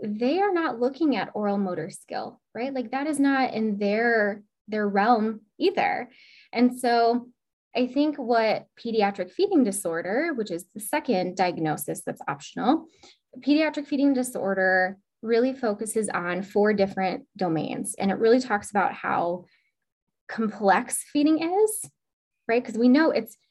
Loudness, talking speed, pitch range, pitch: -25 LUFS, 145 wpm, 200-265 Hz, 230 Hz